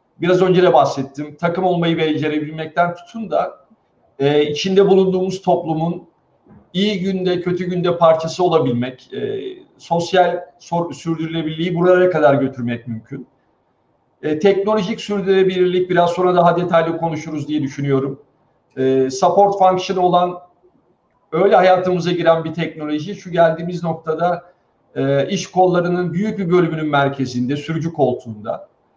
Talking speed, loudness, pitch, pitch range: 110 wpm, -17 LUFS, 170 Hz, 150-180 Hz